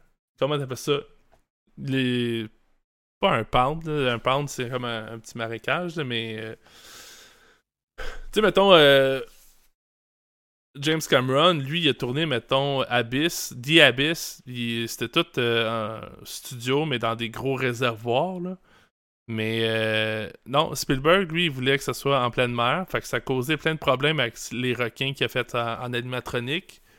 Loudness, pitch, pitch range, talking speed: -24 LUFS, 130 Hz, 115-150 Hz, 165 wpm